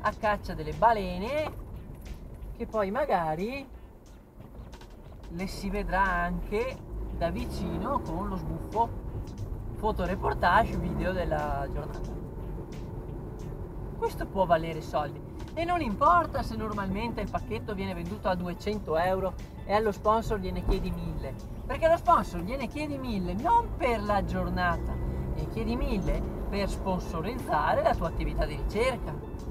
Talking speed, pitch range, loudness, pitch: 125 wpm, 175-225 Hz, -30 LUFS, 200 Hz